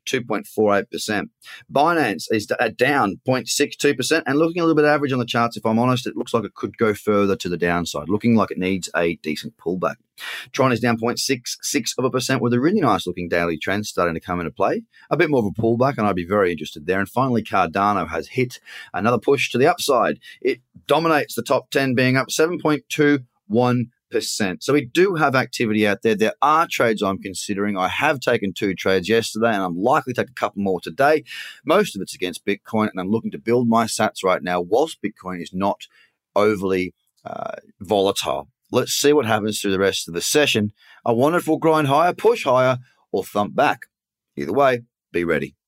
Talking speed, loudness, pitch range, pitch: 205 wpm, -20 LUFS, 100-130 Hz, 115 Hz